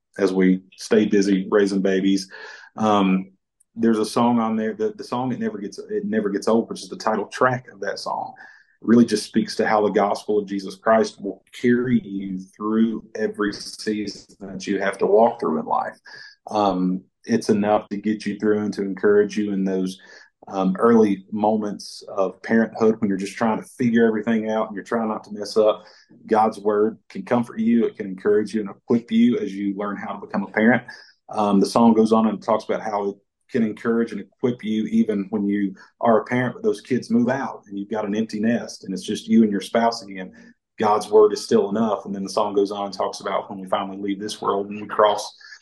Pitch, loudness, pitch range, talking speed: 105 Hz, -22 LUFS, 100-115 Hz, 225 wpm